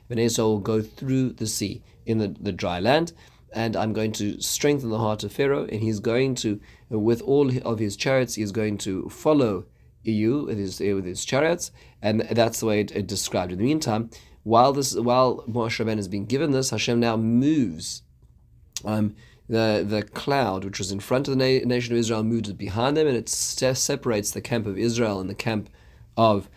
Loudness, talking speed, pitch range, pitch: -24 LUFS, 205 wpm, 105-120 Hz, 110 Hz